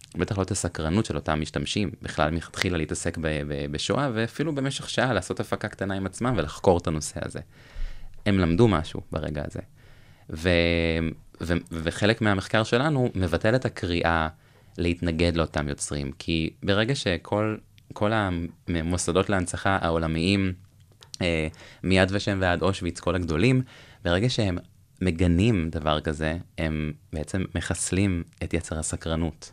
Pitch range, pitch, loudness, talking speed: 80-105 Hz, 90 Hz, -26 LUFS, 130 wpm